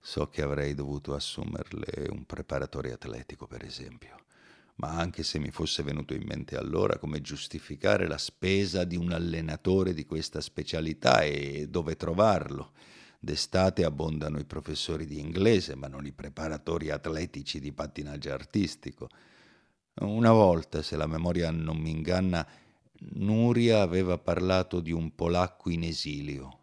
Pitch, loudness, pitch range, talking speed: 80 Hz, -30 LUFS, 75-90 Hz, 140 wpm